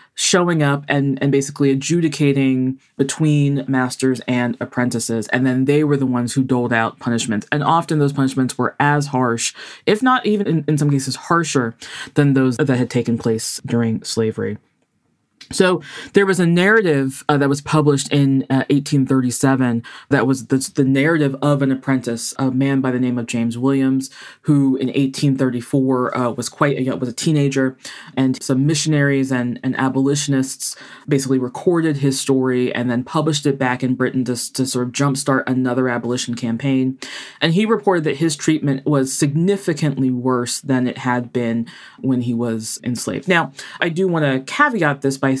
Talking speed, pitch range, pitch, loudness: 175 wpm, 125-145 Hz, 135 Hz, -18 LUFS